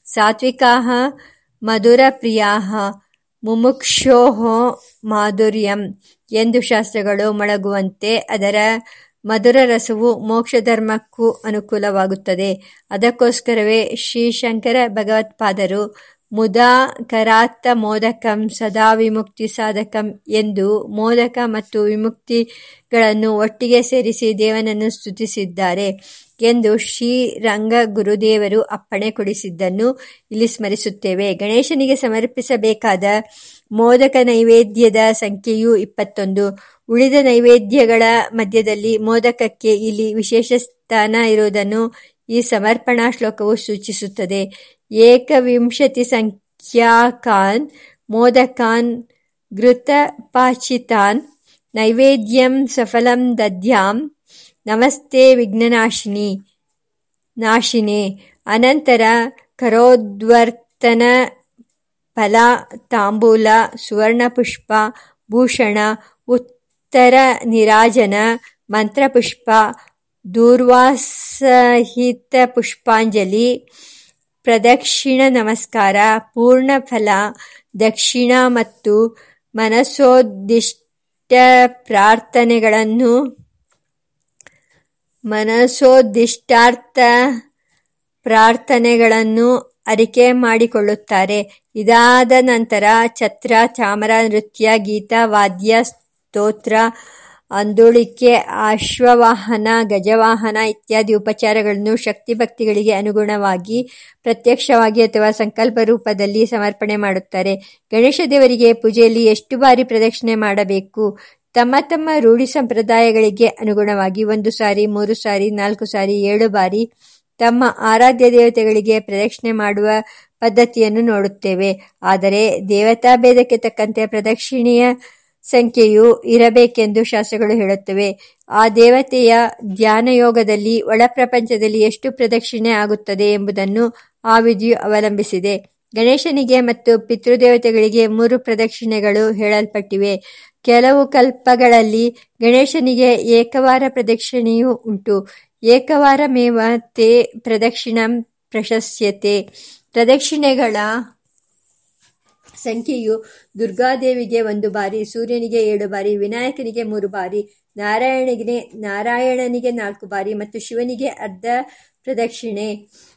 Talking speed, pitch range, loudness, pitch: 70 wpm, 215-245 Hz, -14 LUFS, 225 Hz